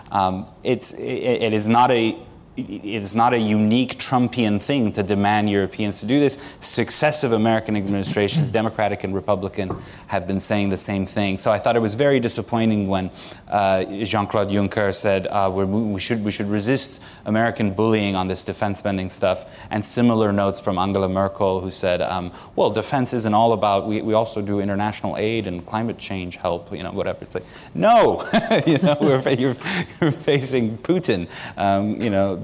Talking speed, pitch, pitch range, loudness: 180 wpm, 105 Hz, 100-115 Hz, -20 LUFS